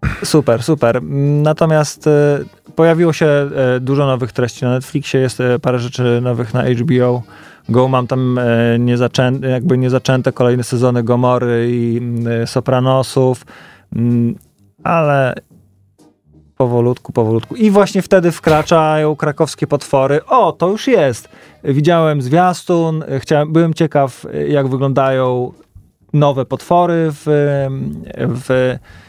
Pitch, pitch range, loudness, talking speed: 130 Hz, 120-150 Hz, -14 LUFS, 105 wpm